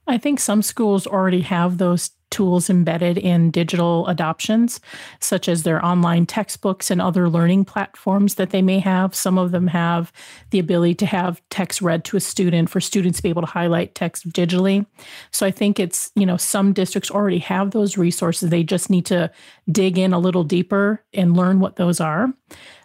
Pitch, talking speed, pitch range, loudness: 185 Hz, 190 wpm, 175-195 Hz, -19 LUFS